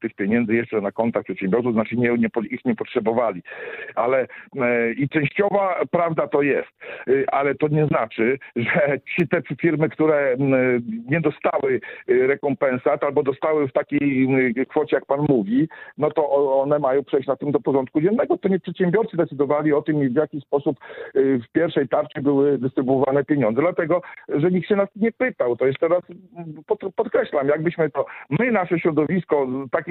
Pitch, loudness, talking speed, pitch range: 150 Hz, -21 LUFS, 165 wpm, 135-170 Hz